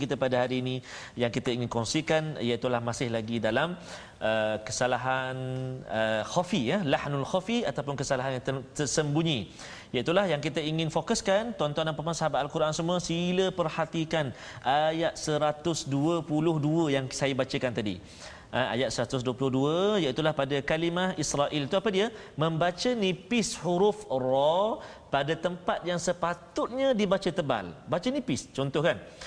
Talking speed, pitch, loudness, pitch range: 140 wpm, 155 Hz, -29 LUFS, 130-175 Hz